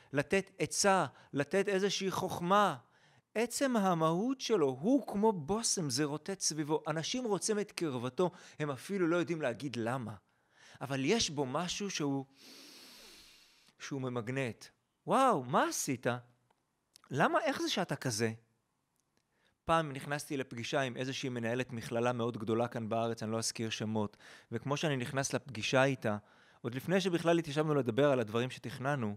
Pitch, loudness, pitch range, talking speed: 145 Hz, -34 LUFS, 120-185 Hz, 140 wpm